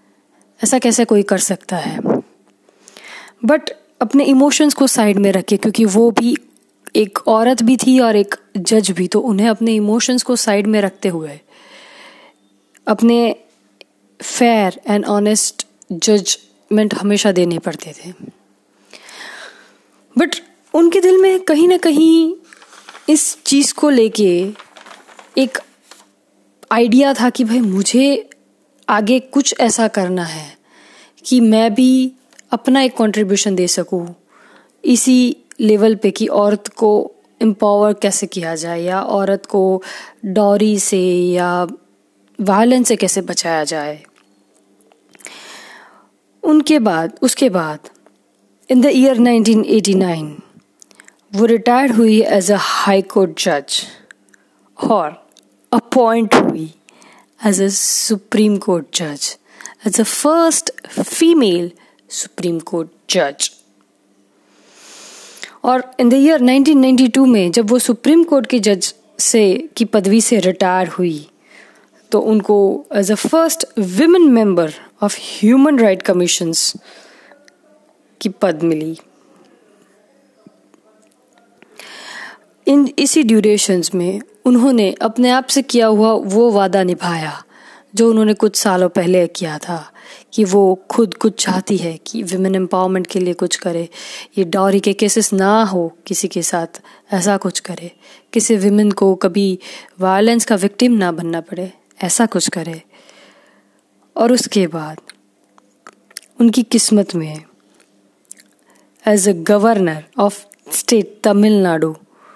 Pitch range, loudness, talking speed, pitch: 185-245 Hz, -14 LUFS, 120 wpm, 210 Hz